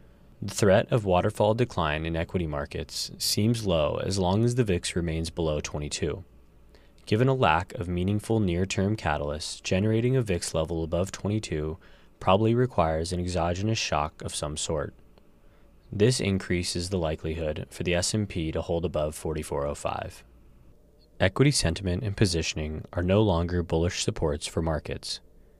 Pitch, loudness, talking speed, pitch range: 90 Hz, -27 LUFS, 145 wpm, 80-105 Hz